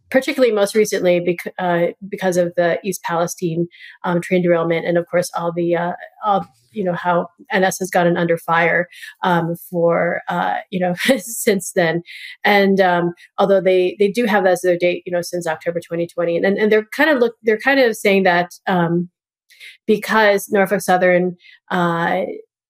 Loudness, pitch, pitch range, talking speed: -18 LUFS, 180 Hz, 170-200 Hz, 180 wpm